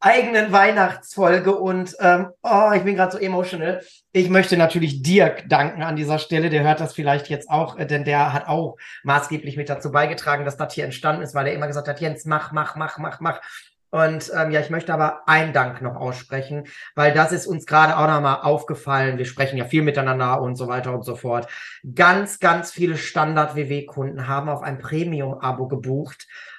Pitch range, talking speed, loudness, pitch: 140-165 Hz, 195 wpm, -20 LUFS, 155 Hz